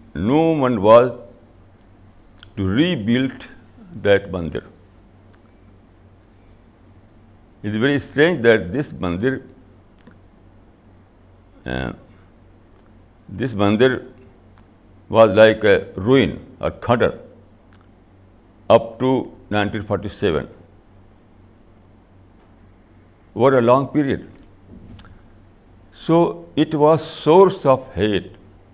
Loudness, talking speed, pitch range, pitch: -18 LUFS, 75 wpm, 95-115 Hz, 105 Hz